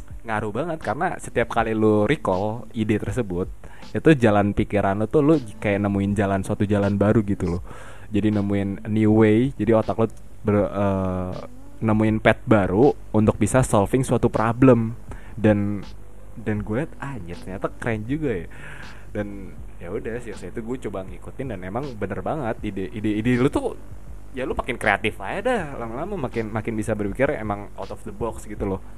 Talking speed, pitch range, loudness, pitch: 180 wpm, 100-115 Hz, -23 LUFS, 105 Hz